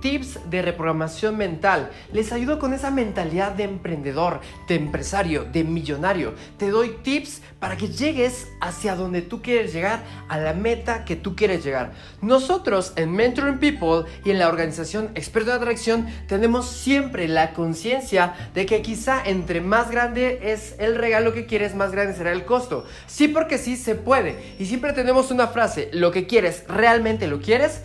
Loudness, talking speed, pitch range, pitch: -22 LUFS, 170 wpm, 175-240 Hz, 215 Hz